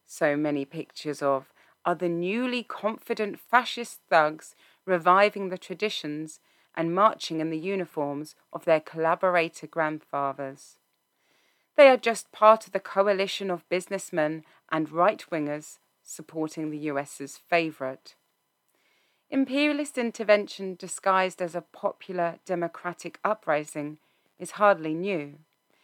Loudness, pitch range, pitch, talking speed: -26 LUFS, 155-200 Hz, 175 Hz, 115 wpm